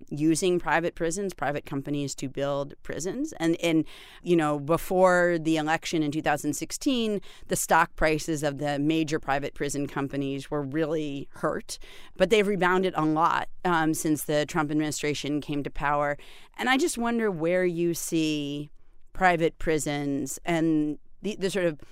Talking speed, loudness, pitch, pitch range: 155 wpm, -27 LUFS, 160 Hz, 145-175 Hz